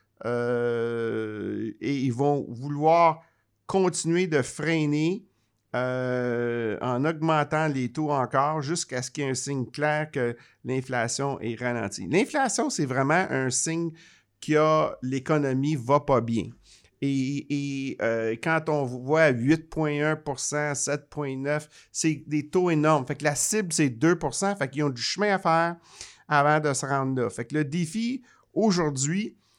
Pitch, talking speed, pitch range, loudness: 145 Hz, 145 wpm, 125-160 Hz, -26 LUFS